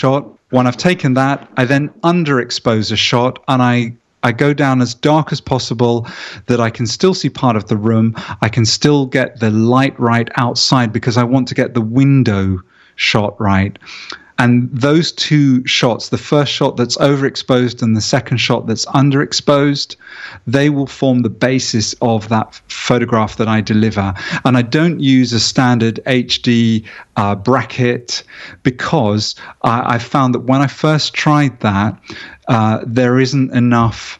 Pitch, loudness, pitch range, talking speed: 125 Hz, -14 LUFS, 115-135 Hz, 165 wpm